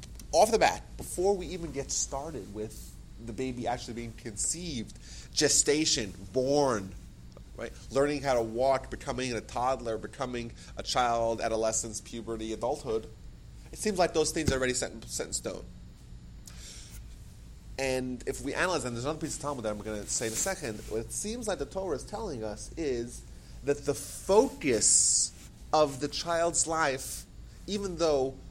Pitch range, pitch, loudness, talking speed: 110-145 Hz, 125 Hz, -30 LUFS, 165 wpm